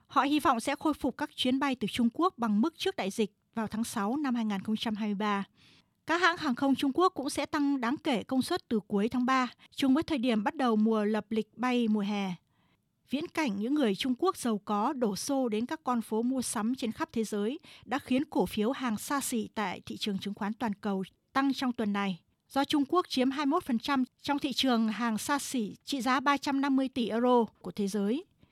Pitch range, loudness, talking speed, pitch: 220-280 Hz, -30 LUFS, 225 wpm, 250 Hz